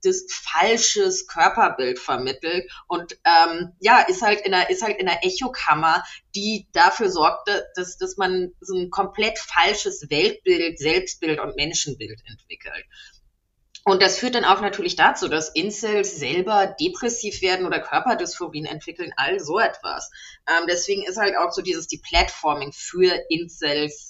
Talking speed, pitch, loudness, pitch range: 150 wpm, 185 Hz, -21 LUFS, 165-220 Hz